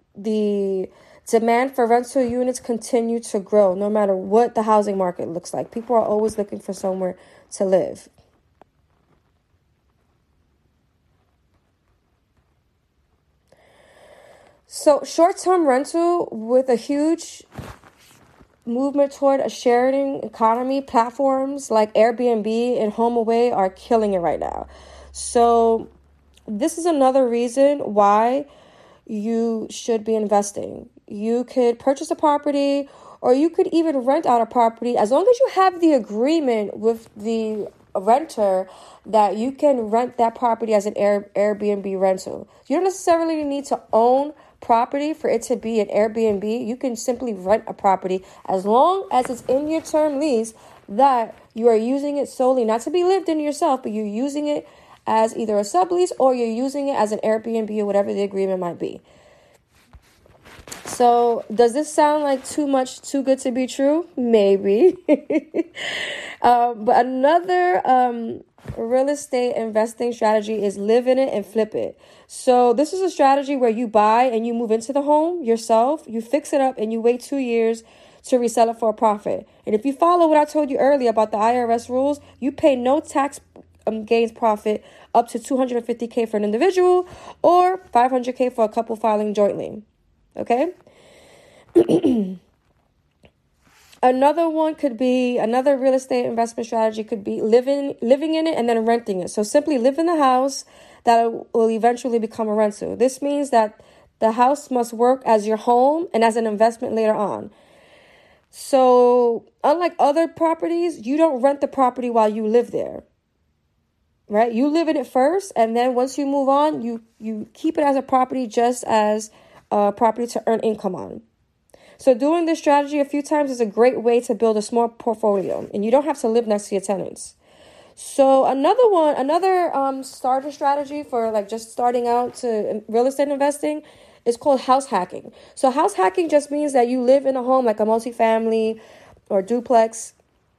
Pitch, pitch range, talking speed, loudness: 245 Hz, 220-280 Hz, 165 wpm, -20 LUFS